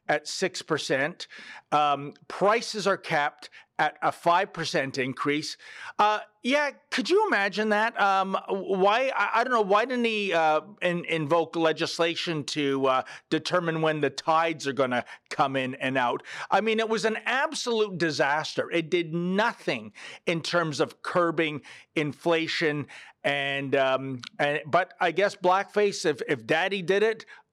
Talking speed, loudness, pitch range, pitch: 150 wpm, -26 LUFS, 150-210 Hz, 170 Hz